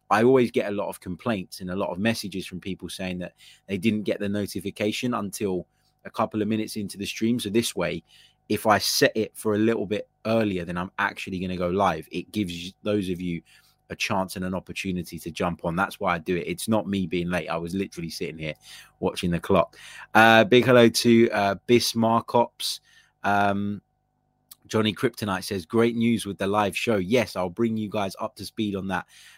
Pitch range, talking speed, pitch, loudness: 90-110 Hz, 215 wpm, 100 Hz, -25 LUFS